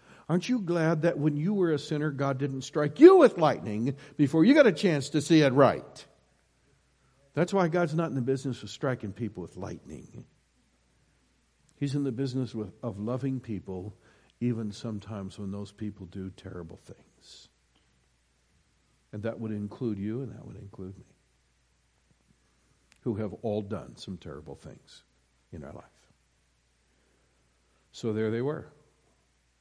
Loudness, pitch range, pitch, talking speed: -27 LUFS, 85-140 Hz, 110 Hz, 150 wpm